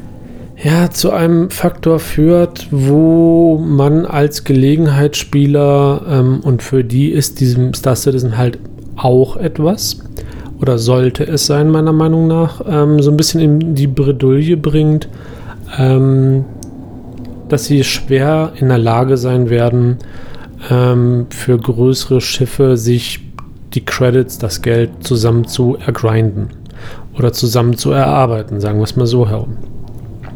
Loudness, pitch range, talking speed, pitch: -12 LUFS, 120-145 Hz, 130 wpm, 130 Hz